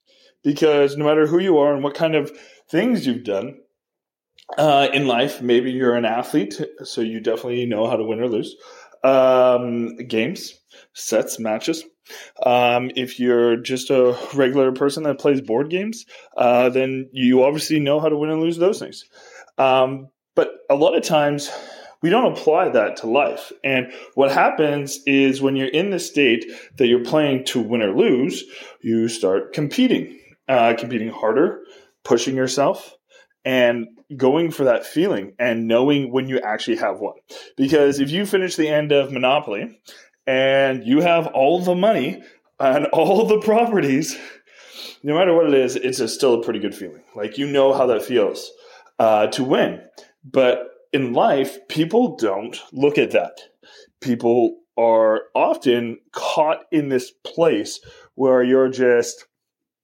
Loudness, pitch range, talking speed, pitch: -19 LUFS, 125-160 Hz, 160 wpm, 135 Hz